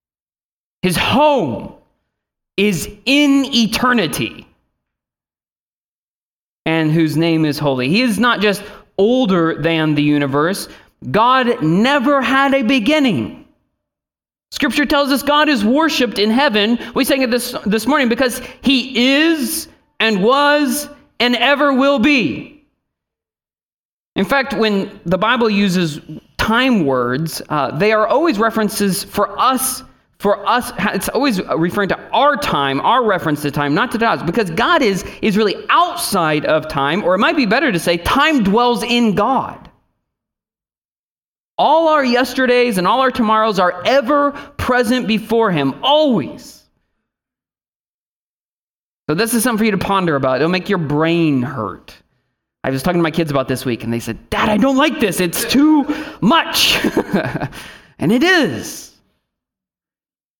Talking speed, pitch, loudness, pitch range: 145 wpm, 225 Hz, -15 LUFS, 180-270 Hz